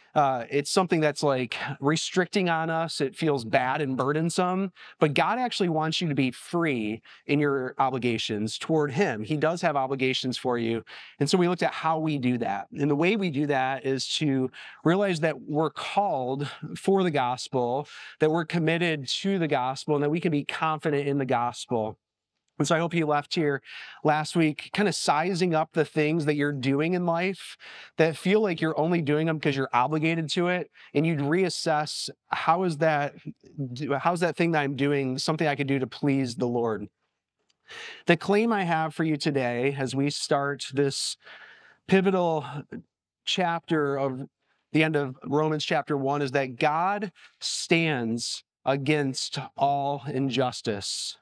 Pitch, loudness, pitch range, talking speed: 150 Hz, -26 LUFS, 135-165 Hz, 175 wpm